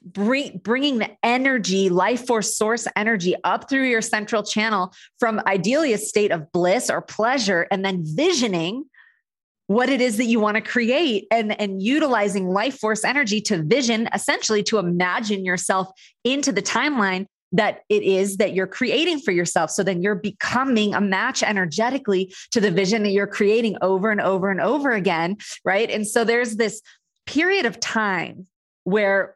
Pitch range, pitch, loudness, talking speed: 195-240 Hz, 215 Hz, -21 LUFS, 170 wpm